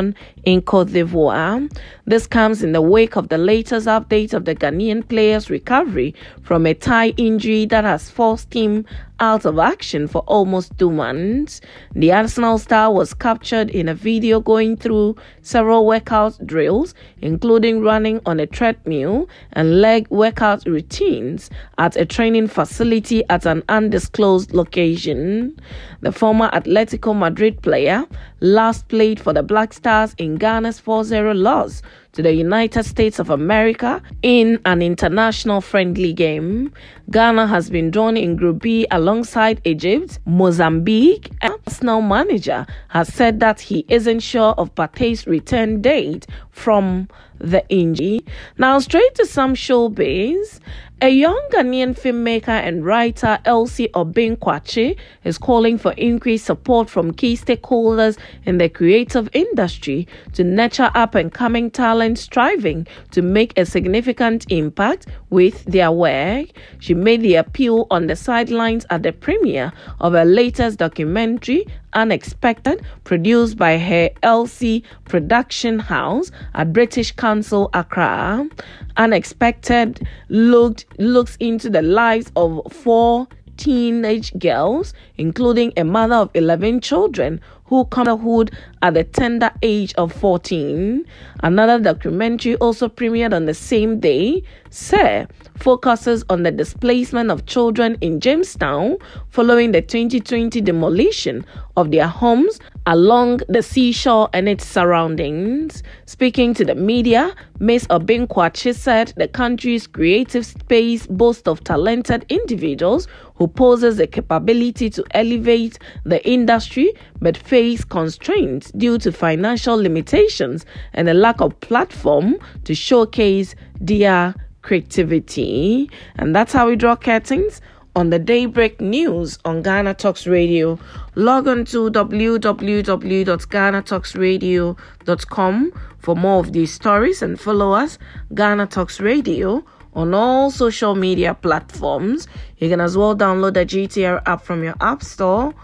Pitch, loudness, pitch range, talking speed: 220 Hz, -16 LUFS, 180-235 Hz, 135 wpm